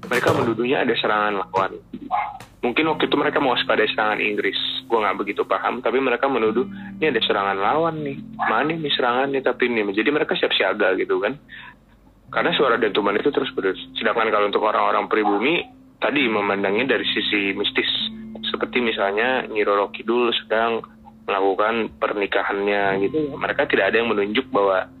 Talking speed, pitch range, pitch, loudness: 160 wpm, 100-155 Hz, 115 Hz, -21 LUFS